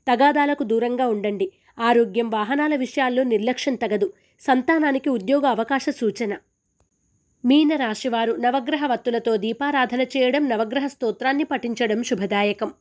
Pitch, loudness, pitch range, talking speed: 245 Hz, -22 LUFS, 225-275 Hz, 100 wpm